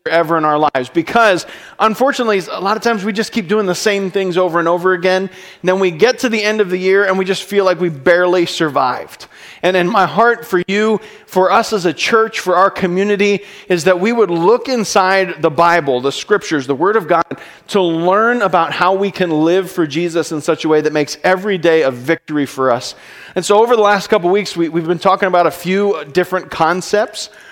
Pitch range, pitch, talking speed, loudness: 170-205 Hz, 185 Hz, 230 wpm, -14 LUFS